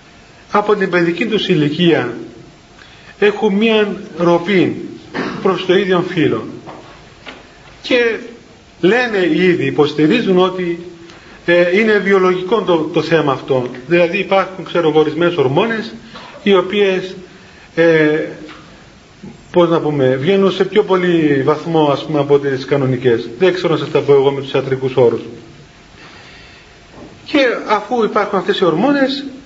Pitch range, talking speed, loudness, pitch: 155-200 Hz, 125 wpm, -14 LUFS, 180 Hz